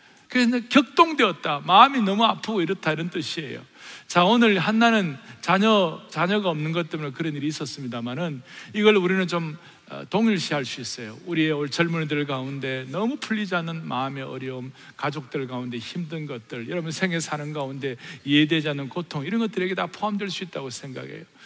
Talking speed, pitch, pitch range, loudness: 385 characters per minute, 165 Hz, 140-195 Hz, -24 LUFS